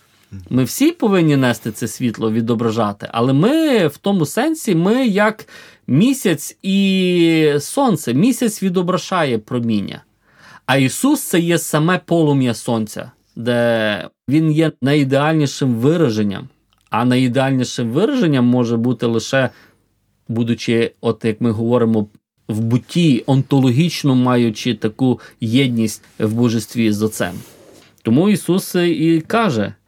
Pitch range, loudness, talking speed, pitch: 115-170 Hz, -17 LUFS, 115 wpm, 130 Hz